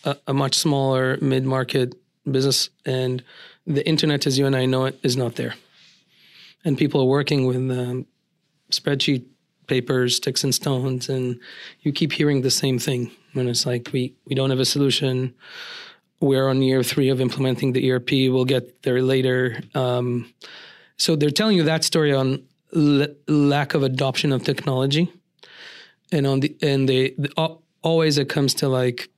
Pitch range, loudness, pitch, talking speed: 130-150 Hz, -21 LUFS, 135 Hz, 170 wpm